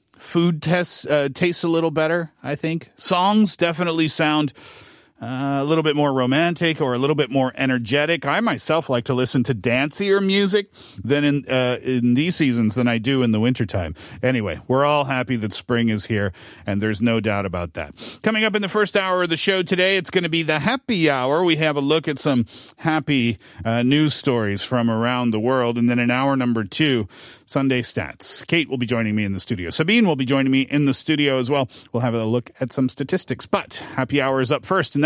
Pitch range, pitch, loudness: 120-160 Hz, 135 Hz, -20 LUFS